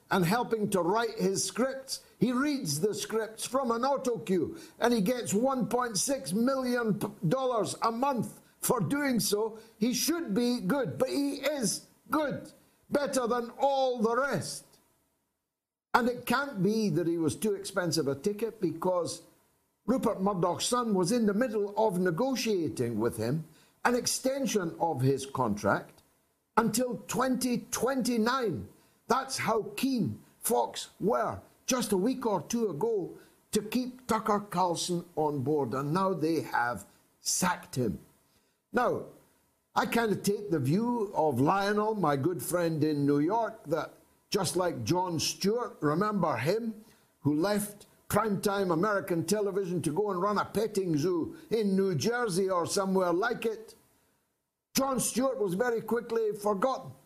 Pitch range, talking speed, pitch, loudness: 180-245 Hz, 145 wpm, 210 Hz, -30 LUFS